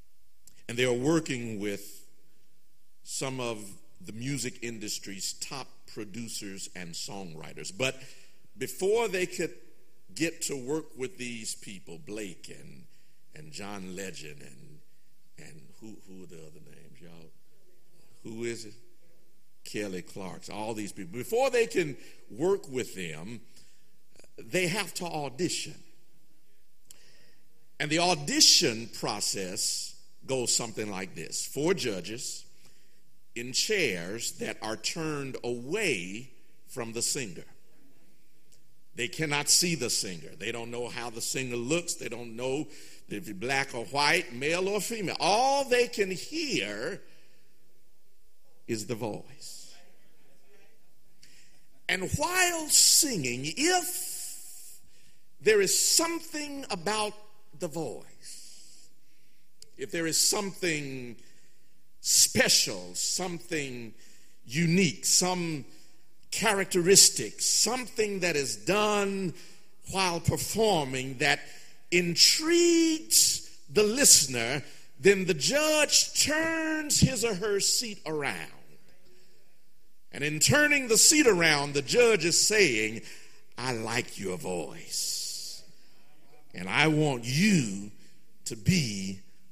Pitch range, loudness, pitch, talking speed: 120-195 Hz, -26 LUFS, 155 Hz, 110 wpm